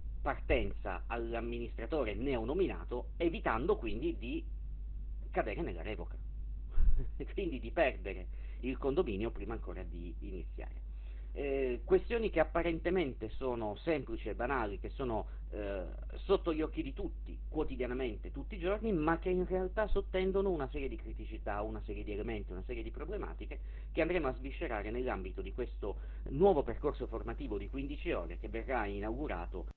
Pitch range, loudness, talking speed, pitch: 105-175 Hz, -38 LUFS, 145 wpm, 130 Hz